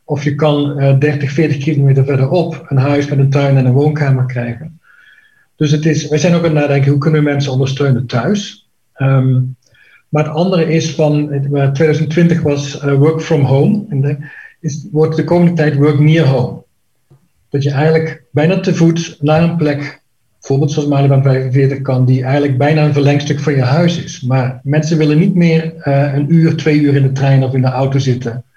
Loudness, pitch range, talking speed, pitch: -13 LUFS, 135-155 Hz, 195 wpm, 145 Hz